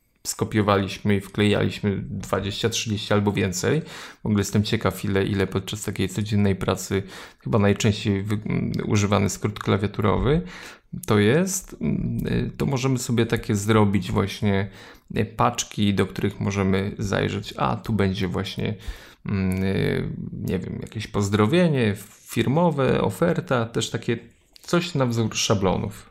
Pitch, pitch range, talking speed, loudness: 105 Hz, 100-115 Hz, 115 wpm, -23 LUFS